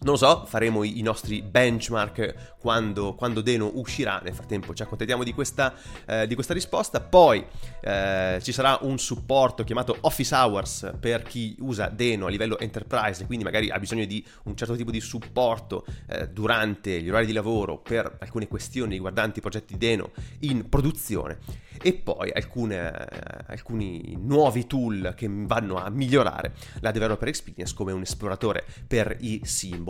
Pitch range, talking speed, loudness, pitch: 105-125 Hz, 165 wpm, -26 LUFS, 110 Hz